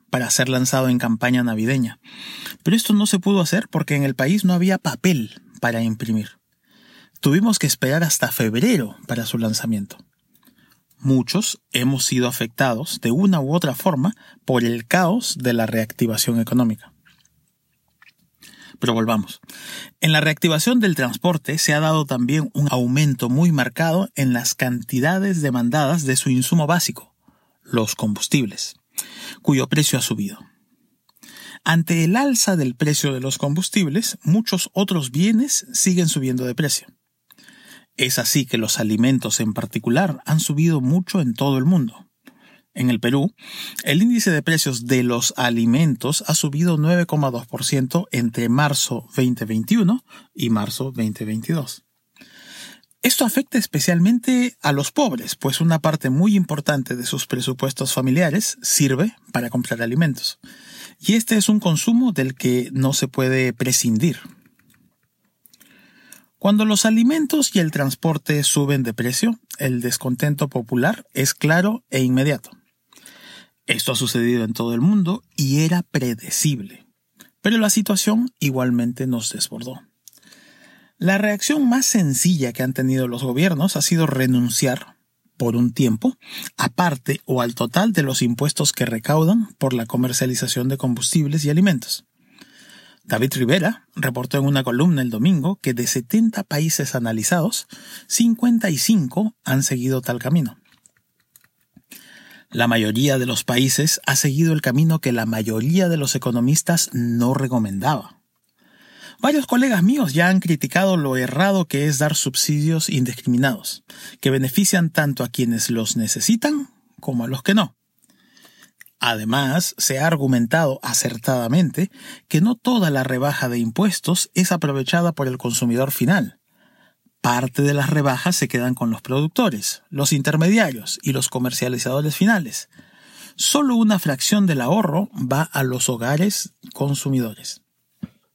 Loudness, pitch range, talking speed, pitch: -19 LUFS, 125-185 Hz, 140 wpm, 145 Hz